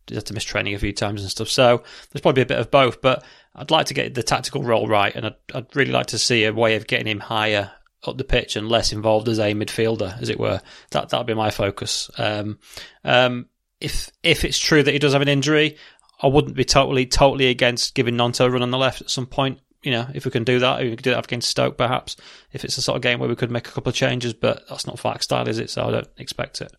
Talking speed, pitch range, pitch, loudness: 280 wpm, 110-130 Hz, 120 Hz, -20 LUFS